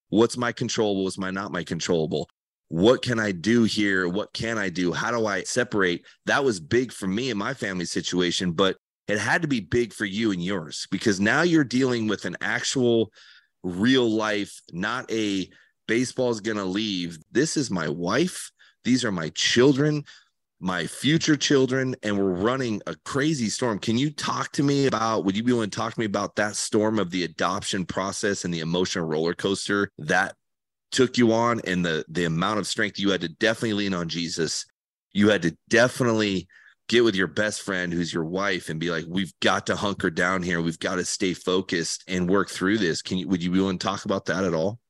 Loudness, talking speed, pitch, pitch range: -24 LUFS, 210 wpm, 100 Hz, 90-115 Hz